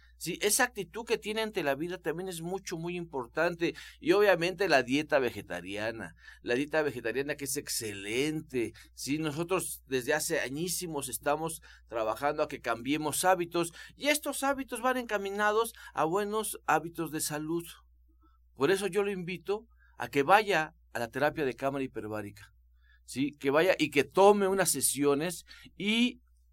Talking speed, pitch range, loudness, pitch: 155 wpm, 130-190 Hz, -30 LUFS, 155 Hz